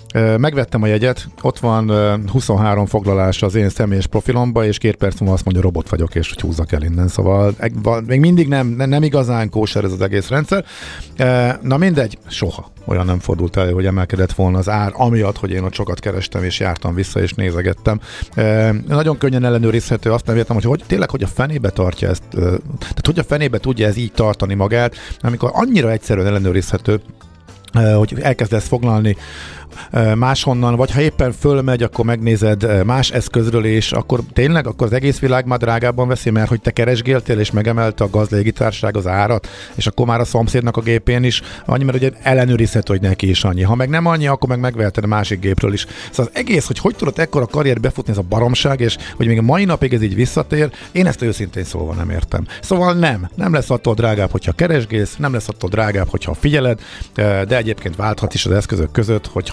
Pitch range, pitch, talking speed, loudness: 100-125 Hz, 110 Hz, 195 wpm, -16 LUFS